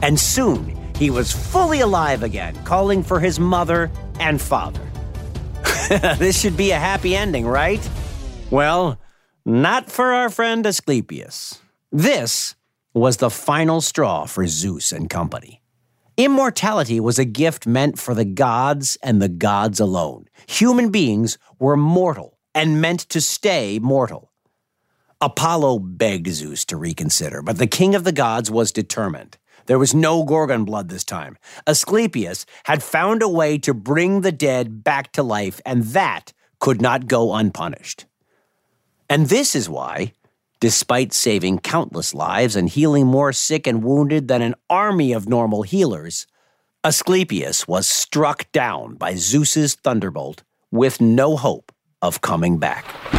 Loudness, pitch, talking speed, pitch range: -18 LUFS, 140 Hz, 145 wpm, 115-170 Hz